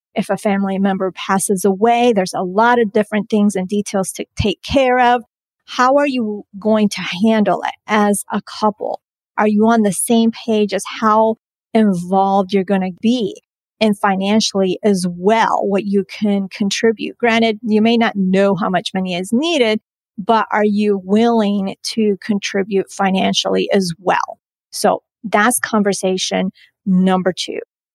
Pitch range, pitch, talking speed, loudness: 195-225 Hz, 210 Hz, 155 wpm, -16 LUFS